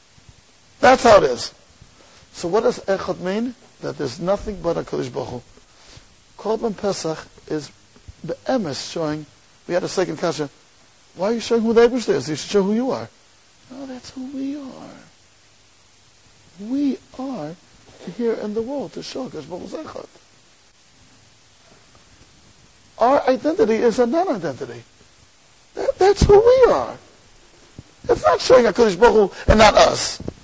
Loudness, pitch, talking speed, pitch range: -19 LUFS, 210 Hz, 150 wpm, 150-255 Hz